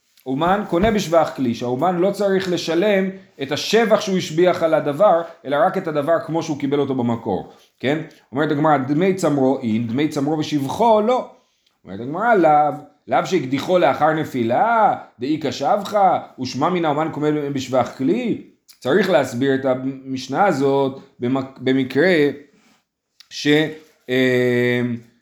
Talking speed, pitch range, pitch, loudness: 135 wpm, 135-170 Hz, 150 Hz, -19 LUFS